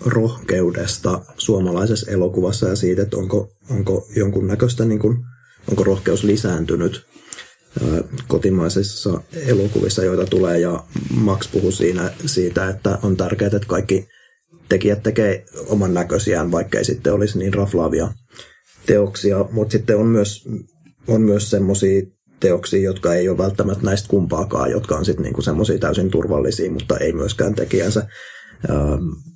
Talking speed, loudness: 125 wpm, -19 LUFS